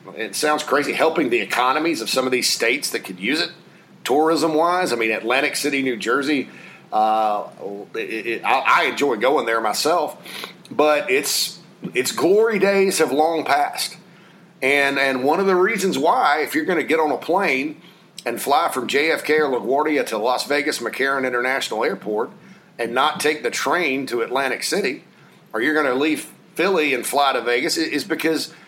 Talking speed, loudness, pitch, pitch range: 185 wpm, -20 LUFS, 150 Hz, 130-180 Hz